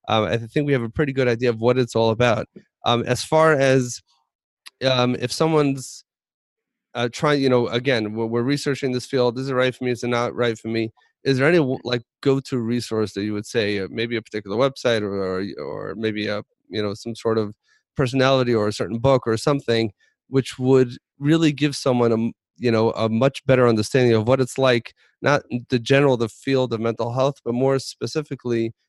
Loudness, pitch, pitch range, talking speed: -21 LUFS, 125 Hz, 115-135 Hz, 210 wpm